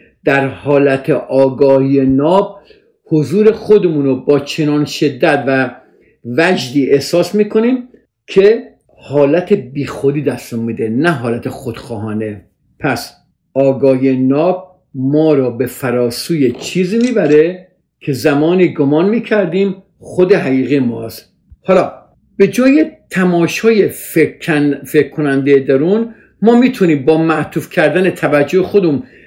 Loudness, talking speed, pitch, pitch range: -13 LUFS, 105 wpm, 150 Hz, 135-185 Hz